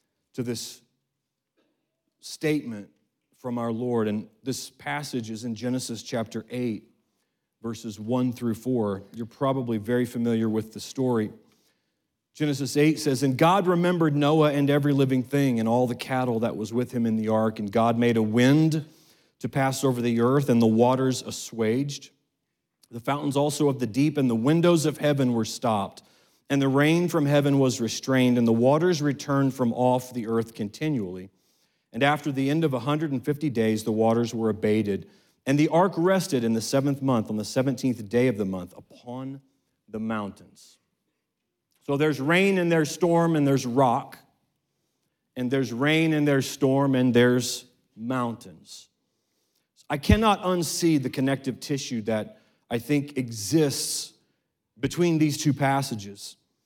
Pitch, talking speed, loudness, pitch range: 130 Hz, 160 wpm, -25 LUFS, 115-145 Hz